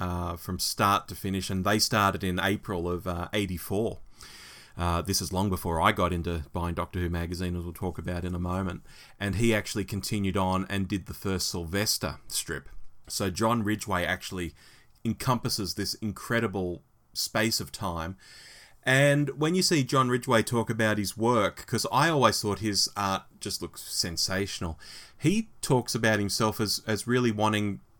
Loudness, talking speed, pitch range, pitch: -28 LUFS, 170 wpm, 90-110 Hz, 100 Hz